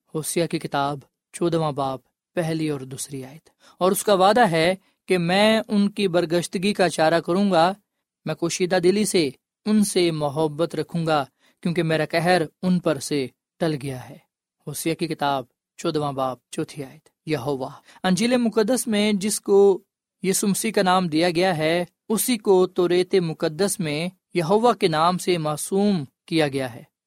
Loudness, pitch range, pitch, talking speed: -22 LUFS, 155-195 Hz, 175 Hz, 165 wpm